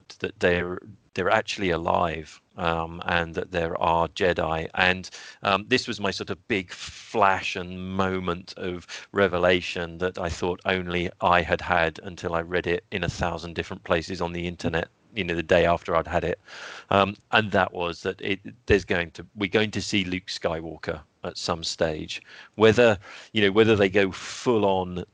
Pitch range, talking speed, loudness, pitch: 85-100 Hz, 195 wpm, -25 LUFS, 90 Hz